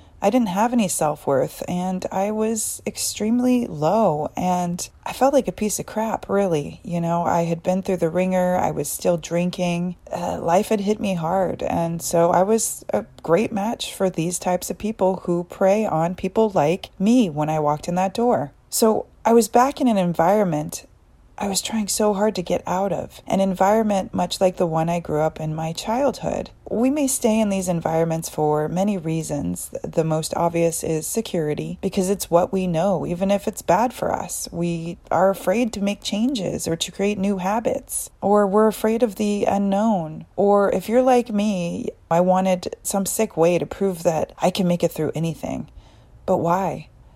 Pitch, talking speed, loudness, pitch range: 190 Hz, 195 wpm, -21 LUFS, 170-215 Hz